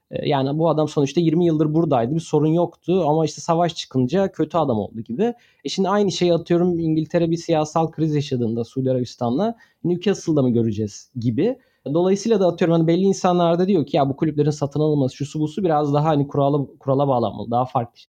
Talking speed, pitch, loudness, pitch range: 185 wpm, 155 Hz, -20 LUFS, 140-175 Hz